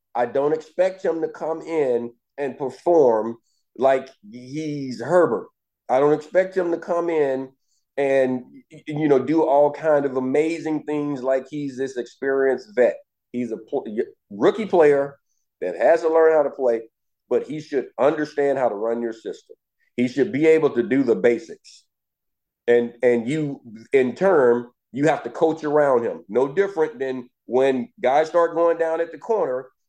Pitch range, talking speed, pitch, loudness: 130-160 Hz, 170 wpm, 145 Hz, -21 LUFS